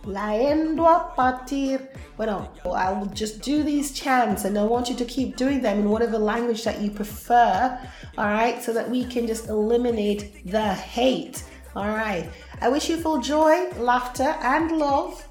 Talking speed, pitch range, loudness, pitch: 160 wpm, 215-275 Hz, -23 LUFS, 240 Hz